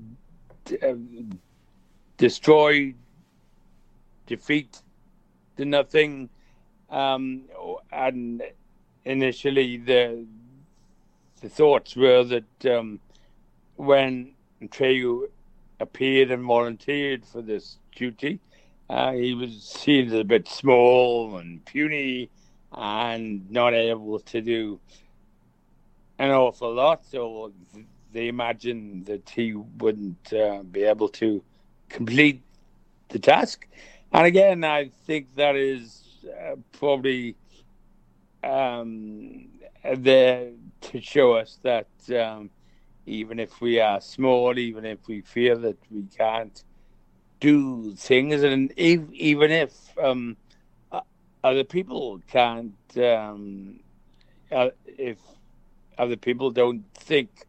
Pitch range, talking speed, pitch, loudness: 110-135 Hz, 100 wpm, 120 Hz, -23 LUFS